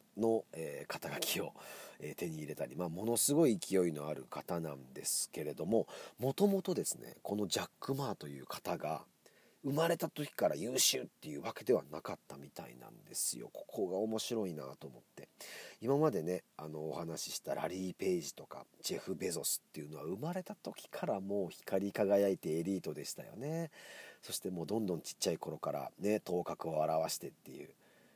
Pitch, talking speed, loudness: 100 Hz, 375 characters per minute, -38 LUFS